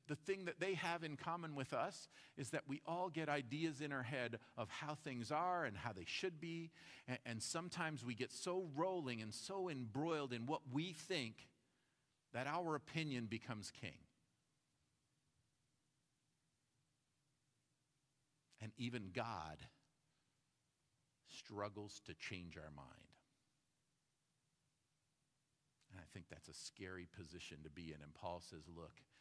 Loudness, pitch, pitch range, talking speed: -47 LUFS, 140 Hz, 115-155 Hz, 140 wpm